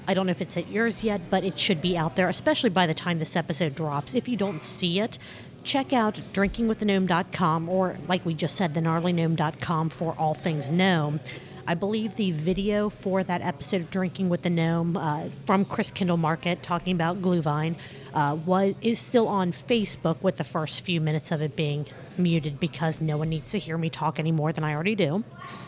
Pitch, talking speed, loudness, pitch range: 175 Hz, 205 wpm, -26 LUFS, 160-190 Hz